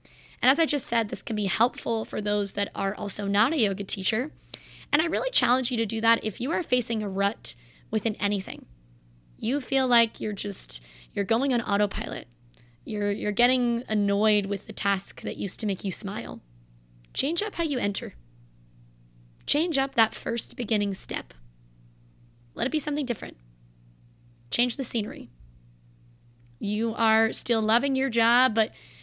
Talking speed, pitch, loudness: 170 wpm, 205 Hz, -26 LUFS